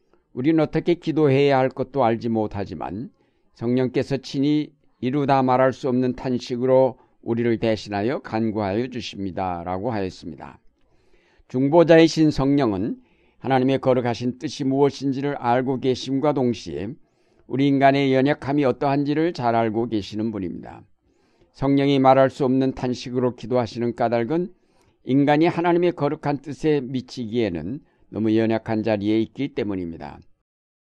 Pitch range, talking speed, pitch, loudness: 115-140 Hz, 325 characters per minute, 130 Hz, -22 LUFS